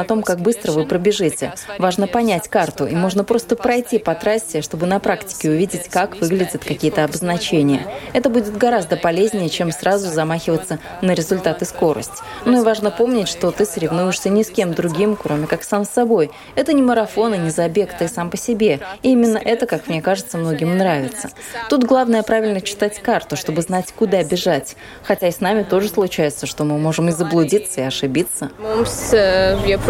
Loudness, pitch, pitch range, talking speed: -18 LUFS, 190 Hz, 165-215 Hz, 180 wpm